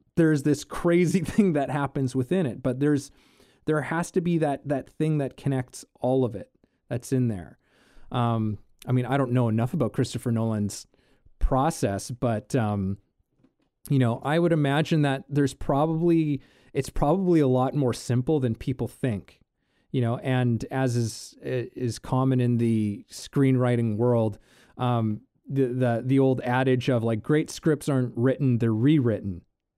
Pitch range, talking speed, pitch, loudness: 120-145 Hz, 160 wpm, 130 Hz, -25 LUFS